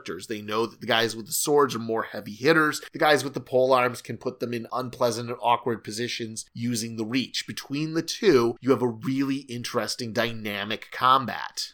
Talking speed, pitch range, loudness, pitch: 200 wpm, 115-130 Hz, -26 LUFS, 120 Hz